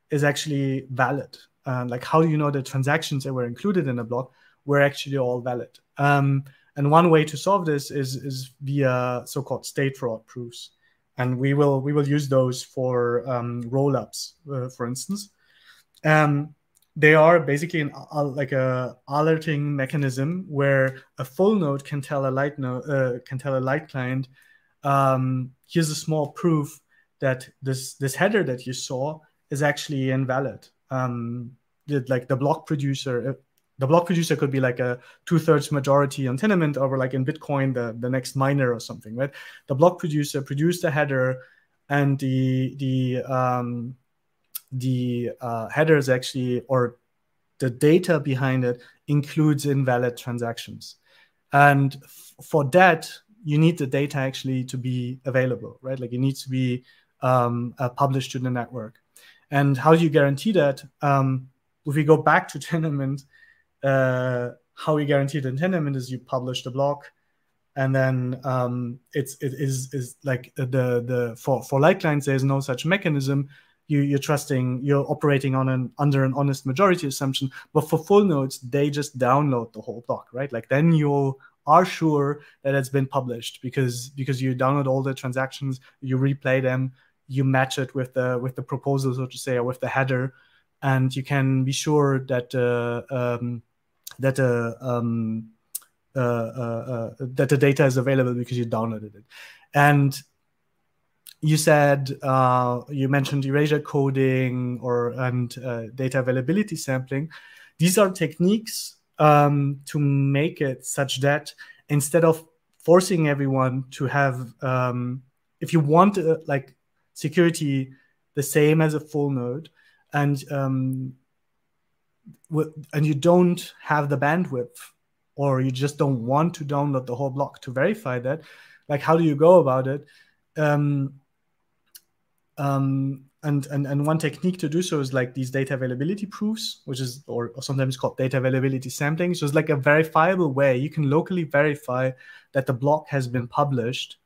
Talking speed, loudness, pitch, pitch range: 165 wpm, -23 LUFS, 135 Hz, 130-150 Hz